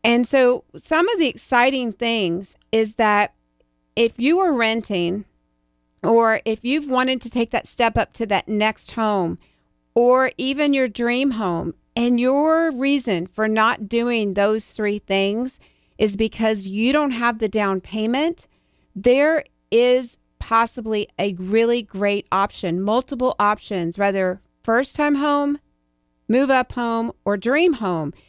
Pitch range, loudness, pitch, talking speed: 200-255 Hz, -20 LUFS, 225 Hz, 140 wpm